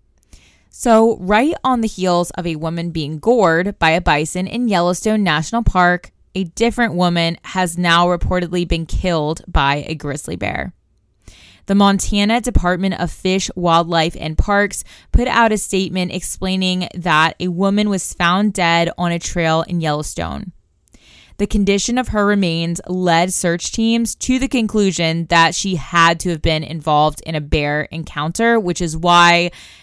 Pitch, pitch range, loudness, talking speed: 175 Hz, 165-200 Hz, -17 LUFS, 155 wpm